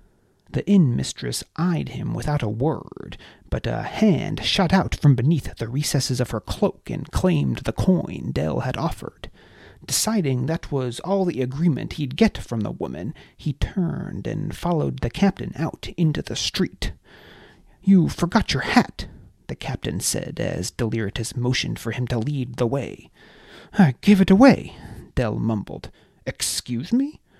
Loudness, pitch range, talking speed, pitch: -23 LUFS, 125-180 Hz, 160 wpm, 150 Hz